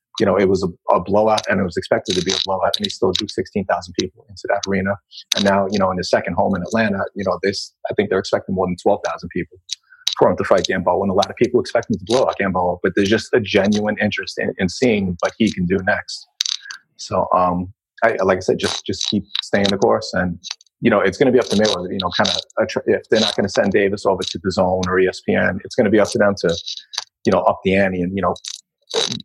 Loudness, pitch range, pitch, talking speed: -19 LUFS, 90-100 Hz, 100 Hz, 270 wpm